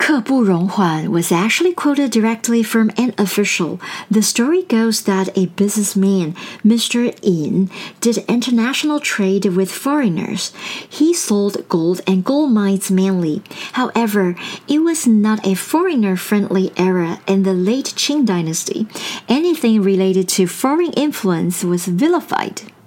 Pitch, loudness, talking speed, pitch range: 210 Hz, -16 LUFS, 130 wpm, 190-245 Hz